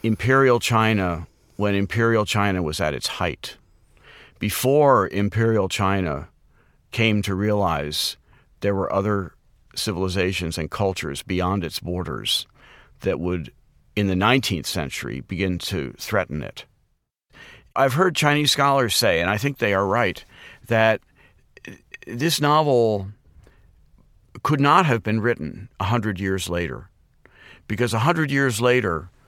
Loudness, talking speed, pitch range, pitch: -22 LUFS, 125 wpm, 95-120 Hz, 105 Hz